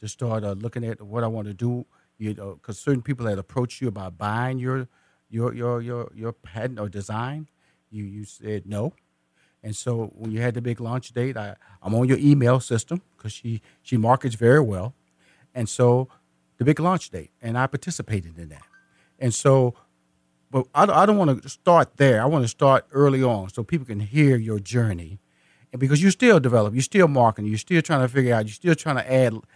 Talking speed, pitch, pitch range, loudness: 215 wpm, 120 Hz, 105-130 Hz, -22 LUFS